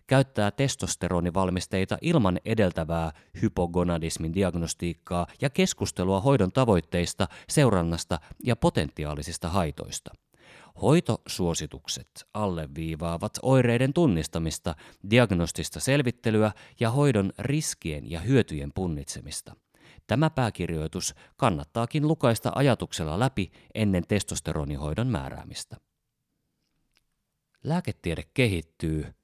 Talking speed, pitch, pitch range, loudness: 75 wpm, 95 Hz, 85-120 Hz, -27 LUFS